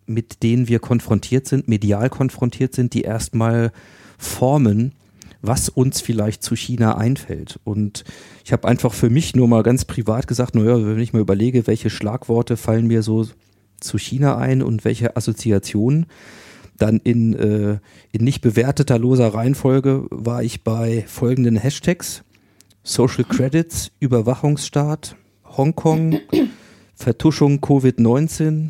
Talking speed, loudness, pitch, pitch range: 130 wpm, -18 LUFS, 120 Hz, 110-130 Hz